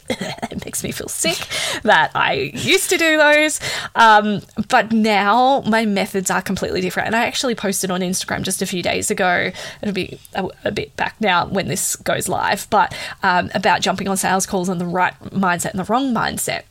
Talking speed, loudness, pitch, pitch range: 200 wpm, -18 LUFS, 195 Hz, 185-230 Hz